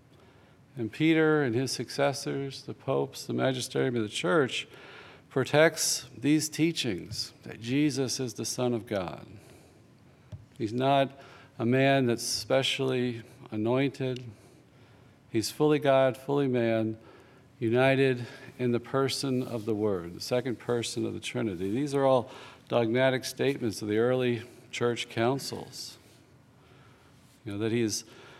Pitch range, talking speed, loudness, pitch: 115-135 Hz, 130 wpm, -29 LUFS, 125 Hz